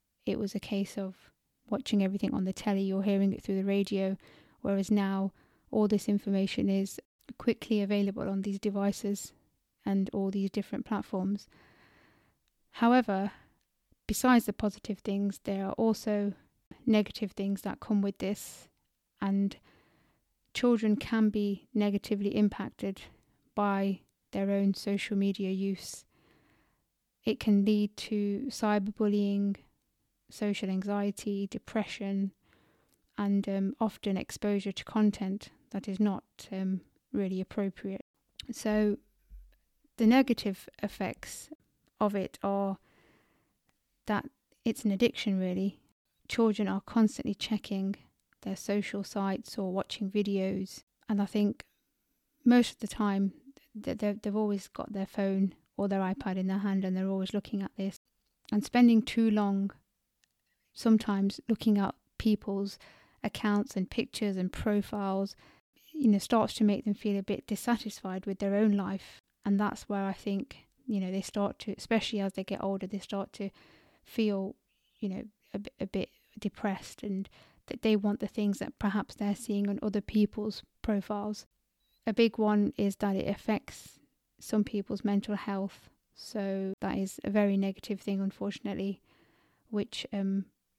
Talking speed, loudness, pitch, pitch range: 140 wpm, -32 LUFS, 205 Hz, 195-215 Hz